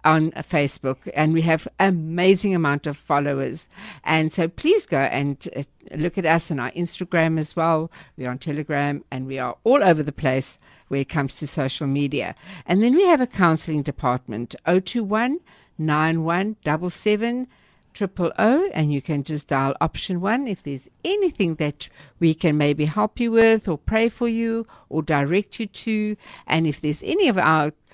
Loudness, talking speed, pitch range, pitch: -22 LUFS, 185 wpm, 145-200 Hz, 160 Hz